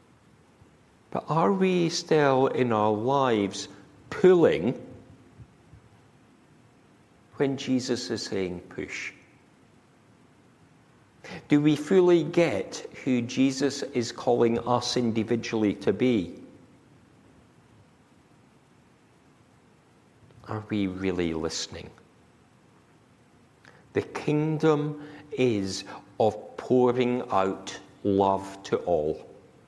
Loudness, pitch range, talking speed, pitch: -26 LUFS, 100-145 Hz, 75 wpm, 125 Hz